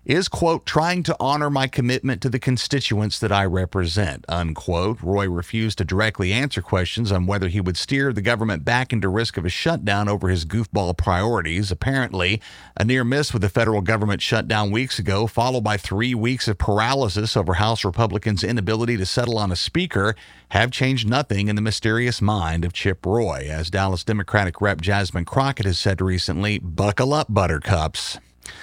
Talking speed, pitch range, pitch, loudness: 180 wpm, 95-120 Hz, 105 Hz, -21 LUFS